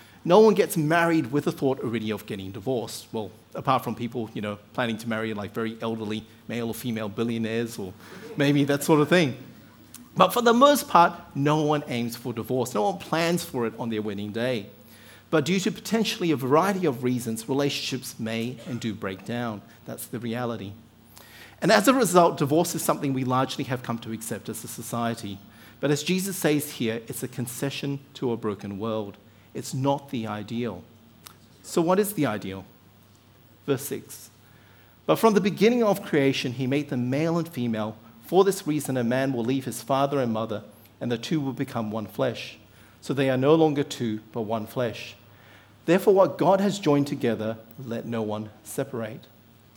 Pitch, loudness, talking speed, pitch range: 120 Hz, -25 LUFS, 190 wpm, 110-145 Hz